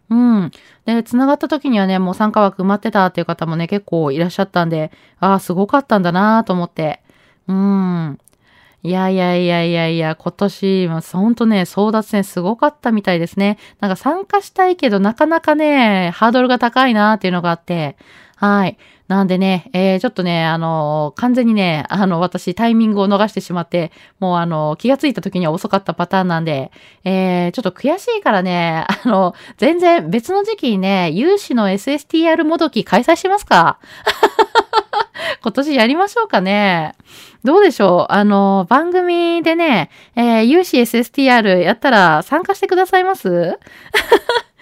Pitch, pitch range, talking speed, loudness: 200 Hz, 180-270 Hz, 355 characters per minute, -15 LUFS